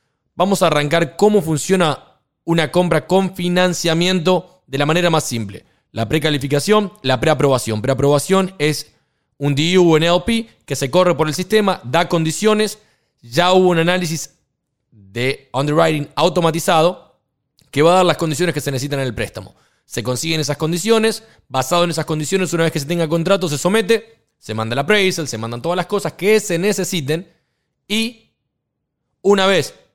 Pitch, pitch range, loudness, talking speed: 165 Hz, 140-180 Hz, -17 LUFS, 165 wpm